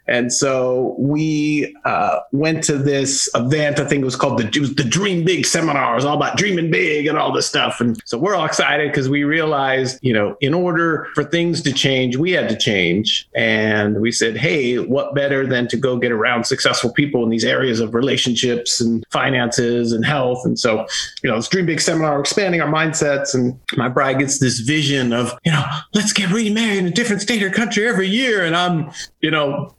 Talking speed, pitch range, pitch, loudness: 215 wpm, 125-165 Hz, 140 Hz, -17 LUFS